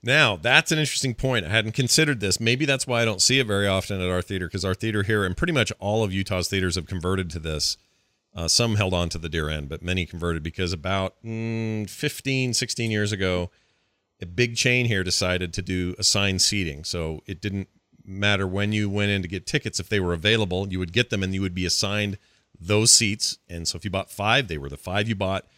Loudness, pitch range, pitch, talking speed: -23 LUFS, 90-115 Hz, 100 Hz, 235 wpm